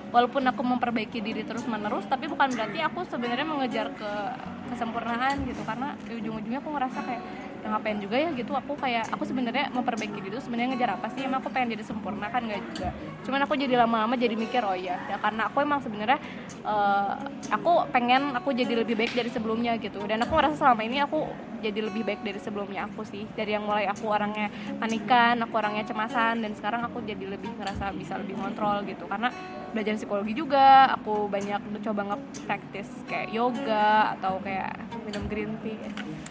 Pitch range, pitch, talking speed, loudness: 215-255 Hz, 230 Hz, 195 wpm, -28 LUFS